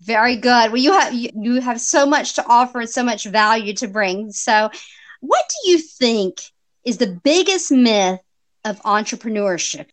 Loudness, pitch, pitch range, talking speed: -17 LUFS, 235 Hz, 215-250 Hz, 170 wpm